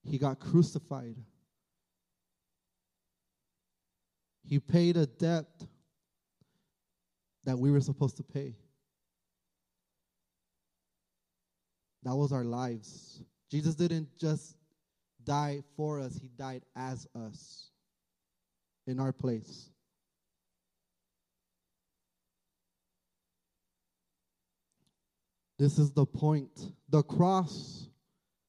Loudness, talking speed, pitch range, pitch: -32 LUFS, 75 wpm, 125-155 Hz, 140 Hz